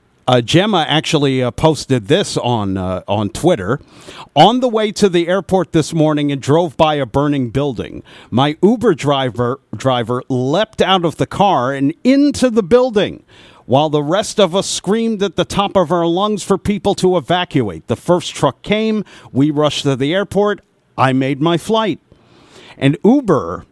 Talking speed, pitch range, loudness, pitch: 170 wpm, 135-195 Hz, -15 LUFS, 160 Hz